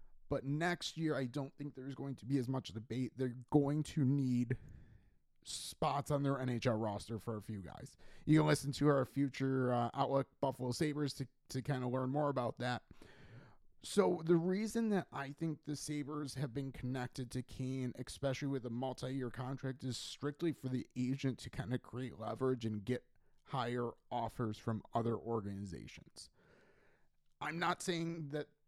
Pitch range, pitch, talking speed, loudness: 125-145 Hz, 130 Hz, 175 wpm, -39 LUFS